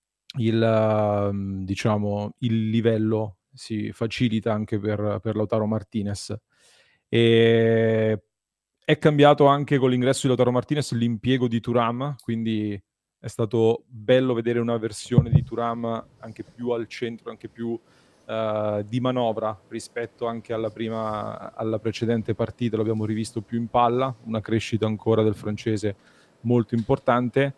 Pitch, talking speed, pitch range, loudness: 115 Hz, 135 wpm, 110-120 Hz, -24 LUFS